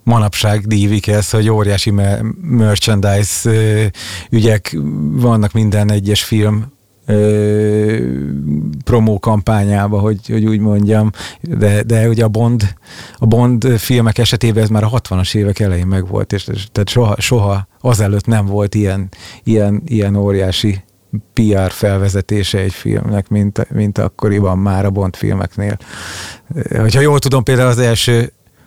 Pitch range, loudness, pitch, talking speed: 100-110 Hz, -14 LUFS, 105 Hz, 125 wpm